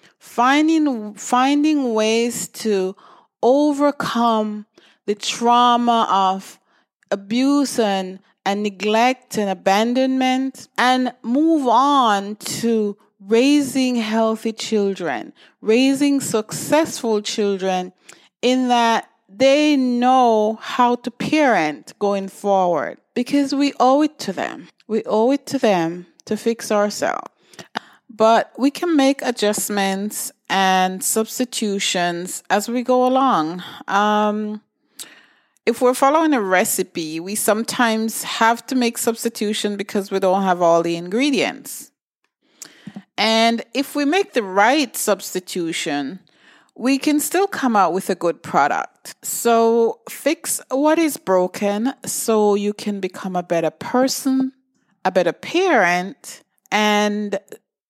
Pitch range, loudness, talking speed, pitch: 200-260 Hz, -19 LUFS, 115 wpm, 225 Hz